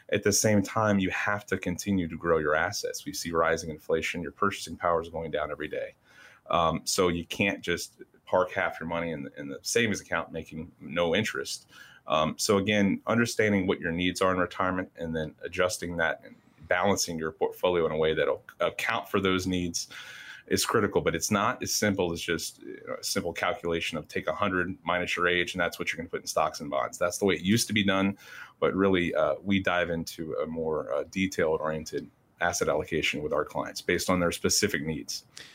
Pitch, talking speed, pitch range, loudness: 95 Hz, 210 wpm, 85-105 Hz, -28 LUFS